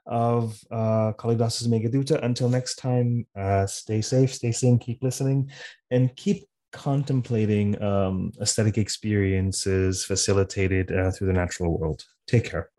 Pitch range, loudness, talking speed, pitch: 100-125 Hz, -25 LUFS, 130 wpm, 110 Hz